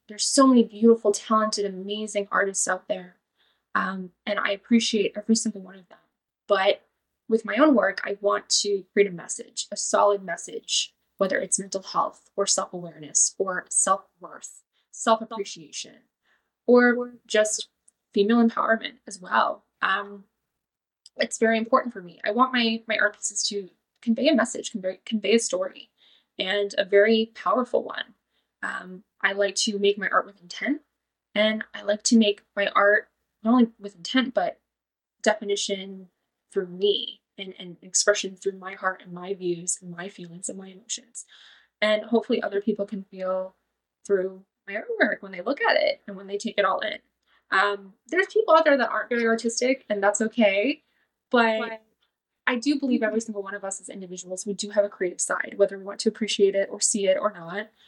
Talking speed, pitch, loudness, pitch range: 180 wpm, 205 Hz, -24 LUFS, 195-230 Hz